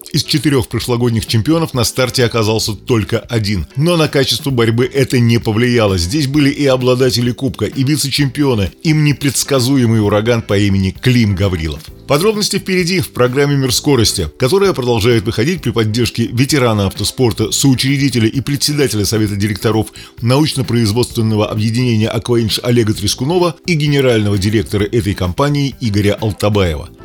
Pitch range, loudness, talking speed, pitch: 110-140 Hz, -14 LUFS, 135 wpm, 120 Hz